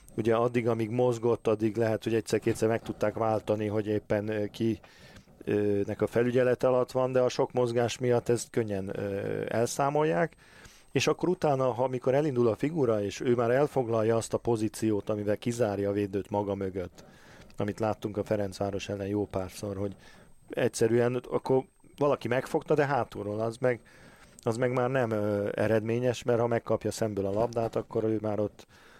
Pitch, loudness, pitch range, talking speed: 115 Hz, -29 LUFS, 105-125 Hz, 165 wpm